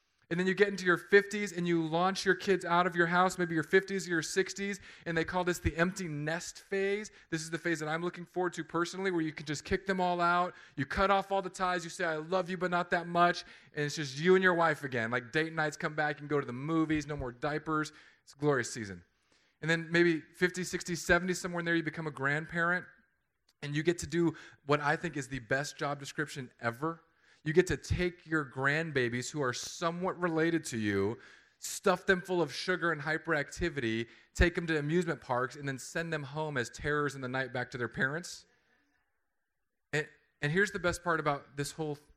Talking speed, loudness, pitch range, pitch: 230 wpm, -32 LUFS, 145-180 Hz, 165 Hz